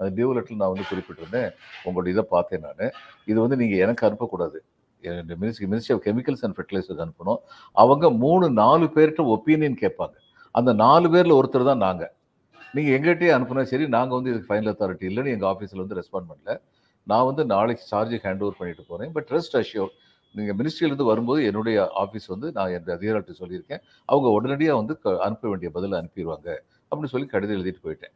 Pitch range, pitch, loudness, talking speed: 95-135 Hz, 110 Hz, -23 LUFS, 175 wpm